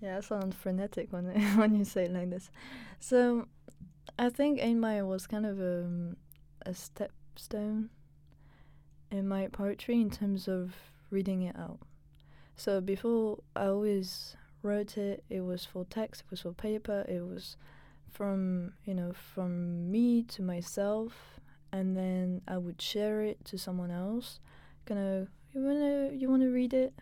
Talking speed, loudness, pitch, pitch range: 160 wpm, -34 LUFS, 195 Hz, 180-215 Hz